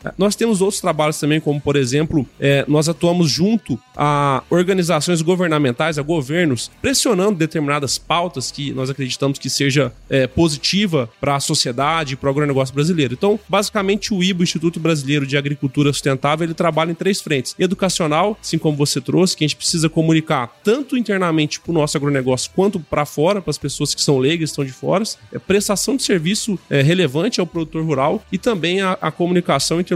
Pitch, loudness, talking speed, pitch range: 160 Hz, -18 LUFS, 180 wpm, 145-185 Hz